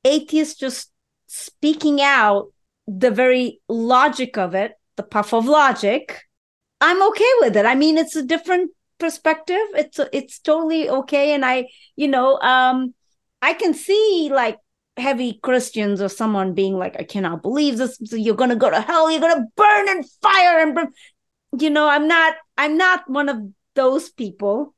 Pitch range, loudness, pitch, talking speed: 240-320 Hz, -18 LUFS, 275 Hz, 175 wpm